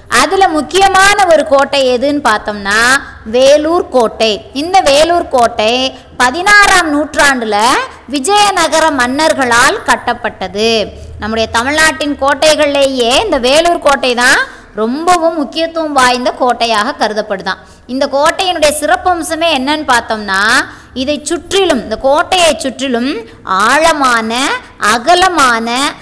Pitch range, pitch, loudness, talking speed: 240-325 Hz, 285 Hz, -10 LUFS, 90 wpm